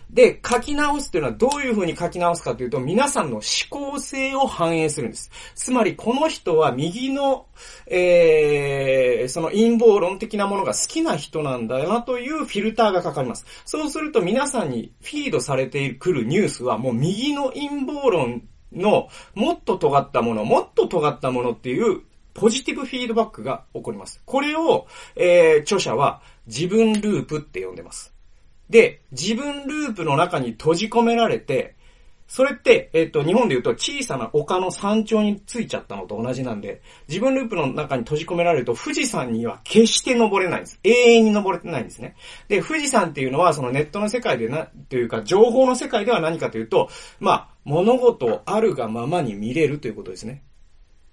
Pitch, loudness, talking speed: 225 Hz, -21 LUFS, 385 characters per minute